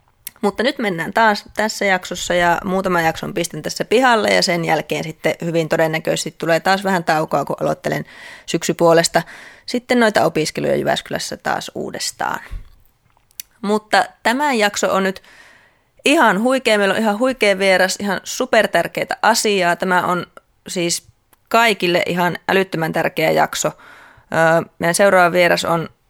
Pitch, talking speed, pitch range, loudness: 185 Hz, 135 wpm, 170-215 Hz, -17 LUFS